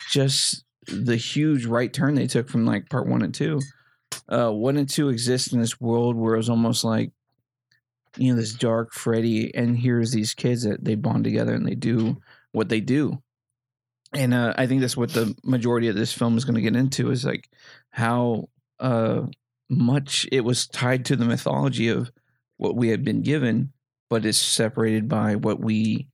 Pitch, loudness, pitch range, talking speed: 120 Hz, -23 LUFS, 115-130 Hz, 195 wpm